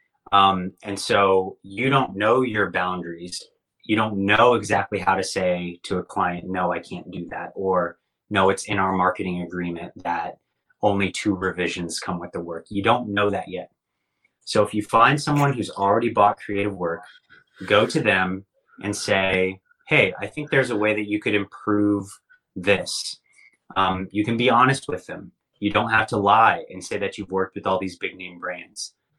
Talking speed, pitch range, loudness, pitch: 190 wpm, 95-105 Hz, -22 LUFS, 100 Hz